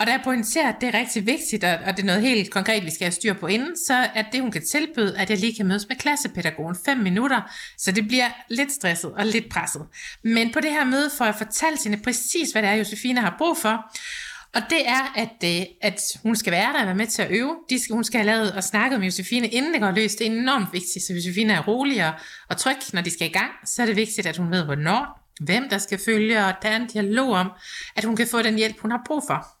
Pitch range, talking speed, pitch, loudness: 195-250 Hz, 270 wpm, 220 Hz, -22 LUFS